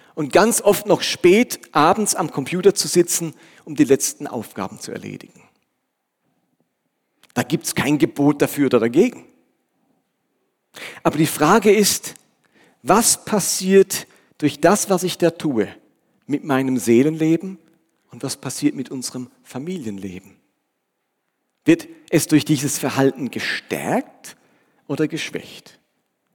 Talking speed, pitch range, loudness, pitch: 120 wpm, 140-185 Hz, -19 LUFS, 155 Hz